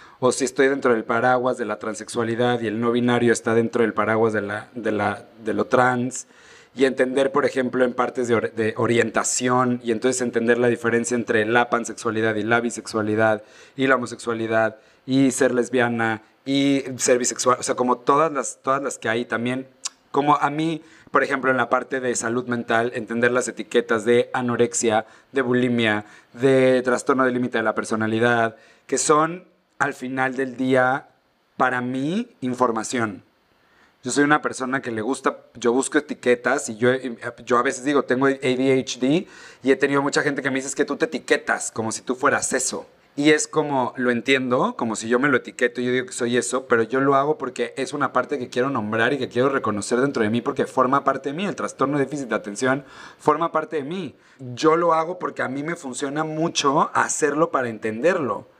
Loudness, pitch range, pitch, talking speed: -22 LUFS, 115-135 Hz, 125 Hz, 200 wpm